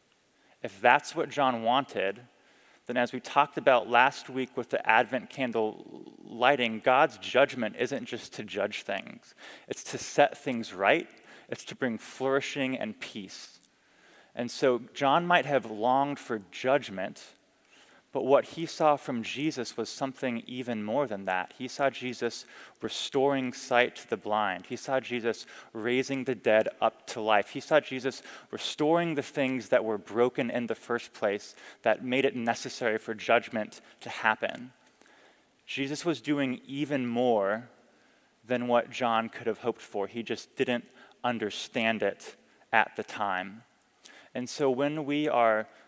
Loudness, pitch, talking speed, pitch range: -29 LUFS, 125 Hz, 155 wpm, 115-135 Hz